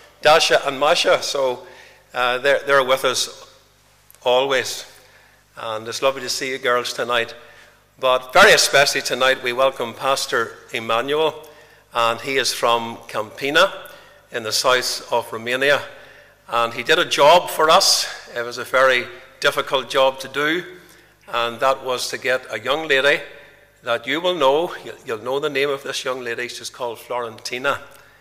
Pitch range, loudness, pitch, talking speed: 120-135 Hz, -19 LUFS, 130 Hz, 155 wpm